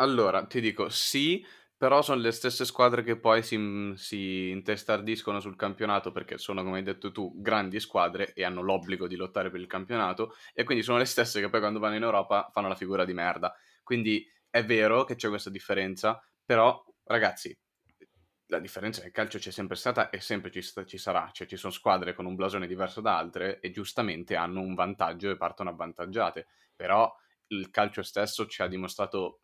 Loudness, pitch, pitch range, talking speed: -30 LUFS, 100 Hz, 95-110 Hz, 195 wpm